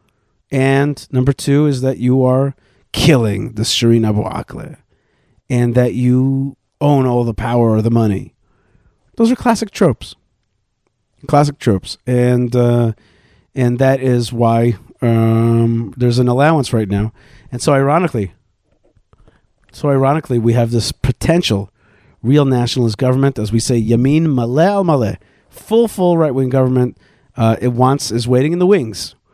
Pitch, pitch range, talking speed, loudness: 125 Hz, 115-140 Hz, 145 wpm, -15 LUFS